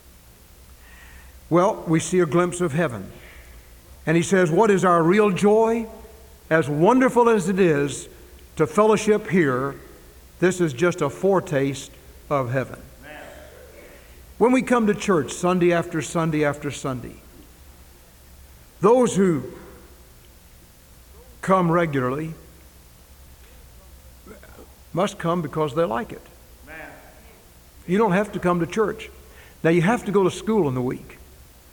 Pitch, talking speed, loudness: 150 Hz, 125 wpm, -21 LUFS